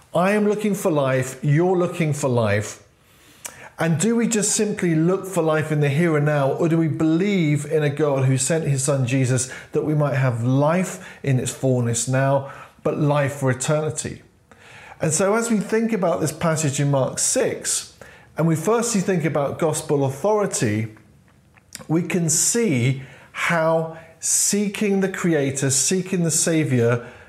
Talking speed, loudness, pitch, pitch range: 165 wpm, -20 LUFS, 155 Hz, 135-180 Hz